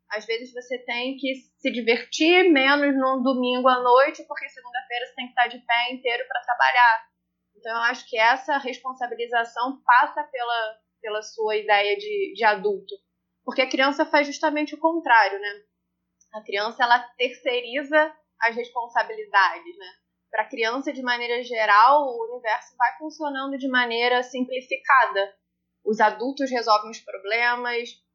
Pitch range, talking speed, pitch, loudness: 225-270 Hz, 150 wpm, 245 Hz, -22 LUFS